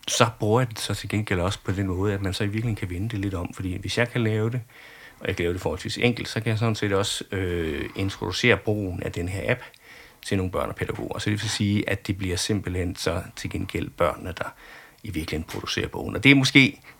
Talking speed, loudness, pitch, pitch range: 260 wpm, -25 LUFS, 105 Hz, 95-115 Hz